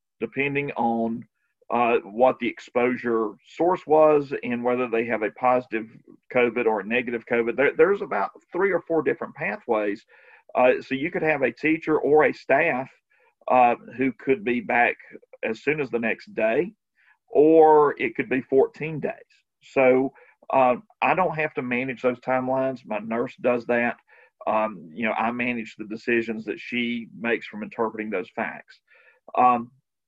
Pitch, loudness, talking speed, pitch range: 125 Hz, -23 LUFS, 165 wpm, 115-140 Hz